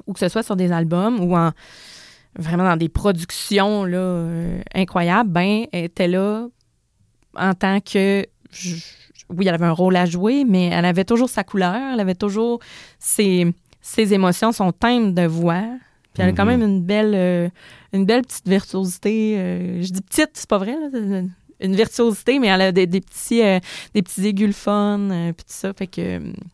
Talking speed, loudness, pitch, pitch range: 195 wpm, -19 LUFS, 190 Hz, 180-210 Hz